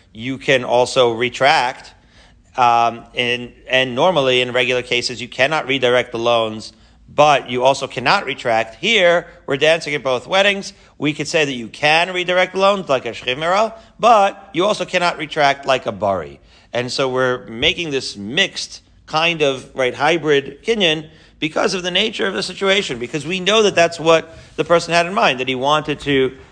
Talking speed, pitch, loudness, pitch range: 180 wpm, 140 Hz, -17 LUFS, 125-170 Hz